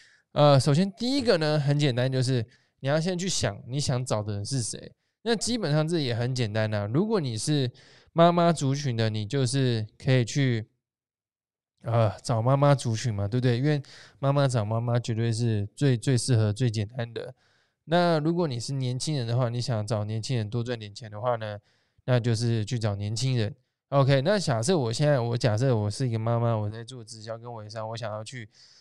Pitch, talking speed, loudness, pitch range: 125 Hz, 290 characters per minute, -26 LUFS, 115-140 Hz